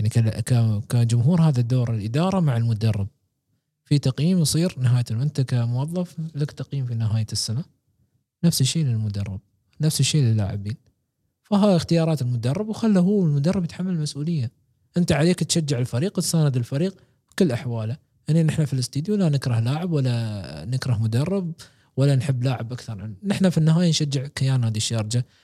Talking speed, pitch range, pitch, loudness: 145 wpm, 115-160 Hz, 135 Hz, -23 LUFS